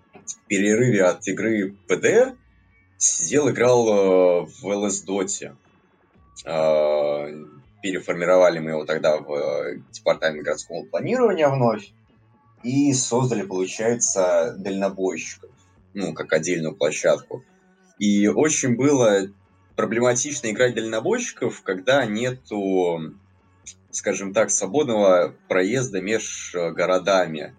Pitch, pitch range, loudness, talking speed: 100 Hz, 95-120 Hz, -21 LUFS, 90 wpm